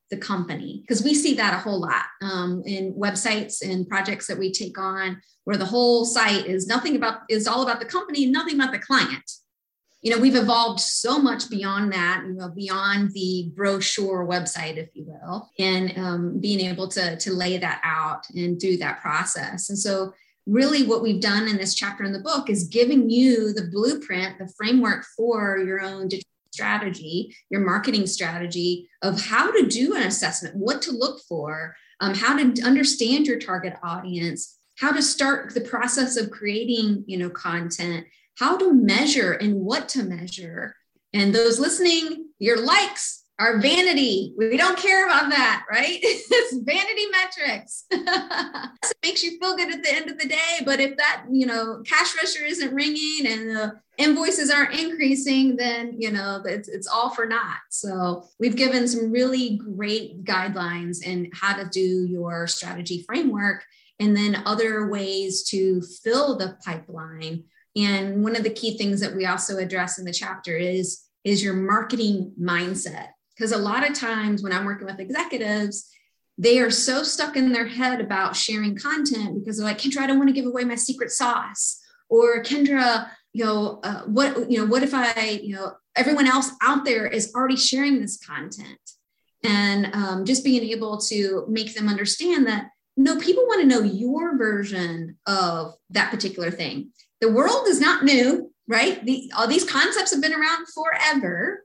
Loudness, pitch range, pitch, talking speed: -22 LUFS, 190-270 Hz, 220 Hz, 180 wpm